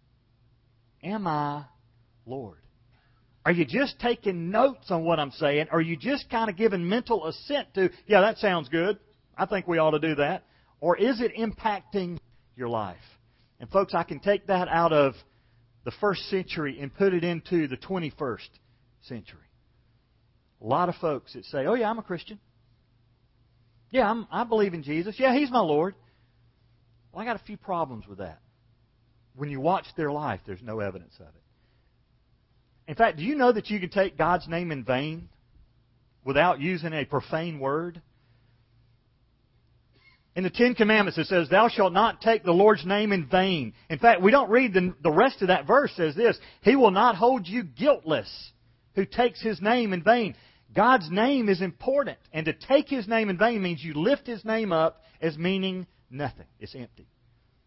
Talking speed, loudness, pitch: 185 wpm, -25 LUFS, 165 Hz